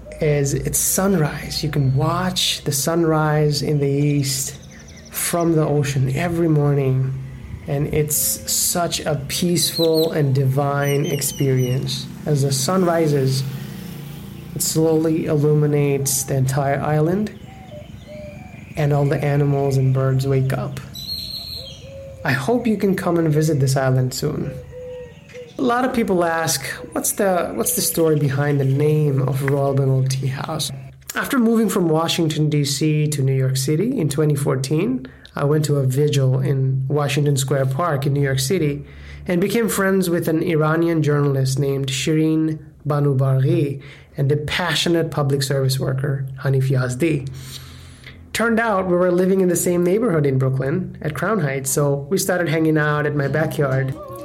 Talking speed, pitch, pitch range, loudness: 150 wpm, 150 Hz, 135-165 Hz, -19 LUFS